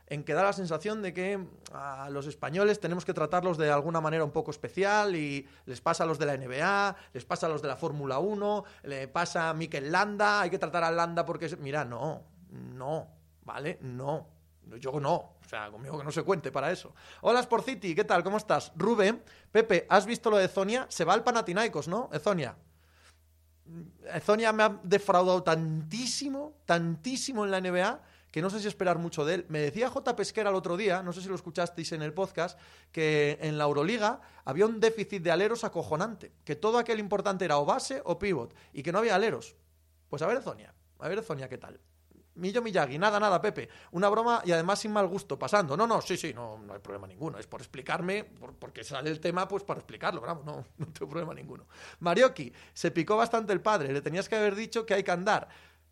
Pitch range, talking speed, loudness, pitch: 150-205 Hz, 215 wpm, -30 LUFS, 175 Hz